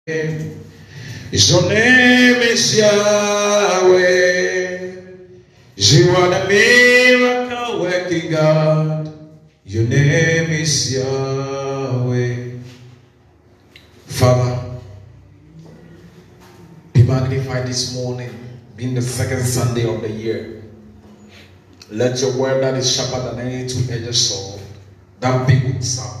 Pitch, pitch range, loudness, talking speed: 130 Hz, 120-165 Hz, -15 LUFS, 90 wpm